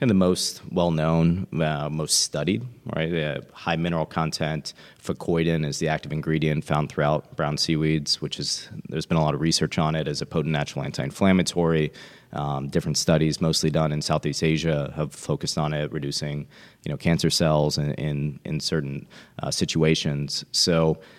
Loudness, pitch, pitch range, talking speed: -24 LUFS, 80 Hz, 75-80 Hz, 175 wpm